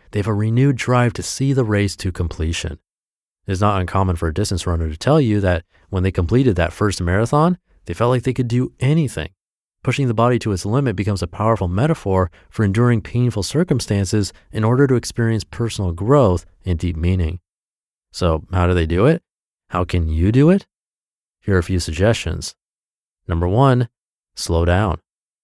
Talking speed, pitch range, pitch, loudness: 185 wpm, 90-120 Hz, 100 Hz, -19 LUFS